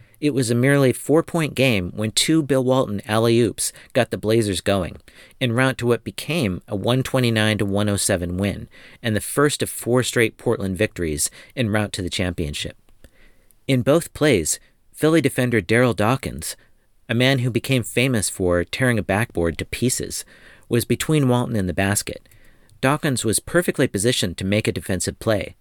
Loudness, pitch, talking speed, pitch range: -21 LUFS, 115 Hz, 165 wpm, 100-130 Hz